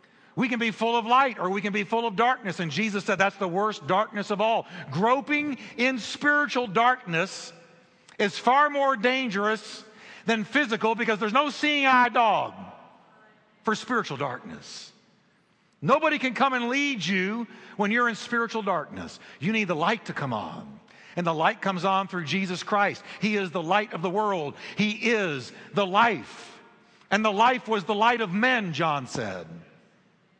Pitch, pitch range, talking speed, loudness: 215 Hz, 195-240 Hz, 175 wpm, -25 LUFS